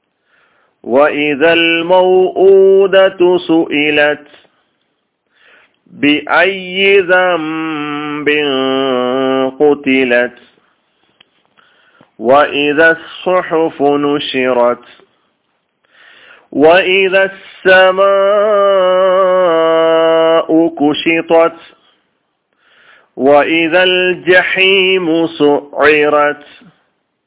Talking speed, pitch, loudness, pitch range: 35 wpm, 165 Hz, -10 LUFS, 145-185 Hz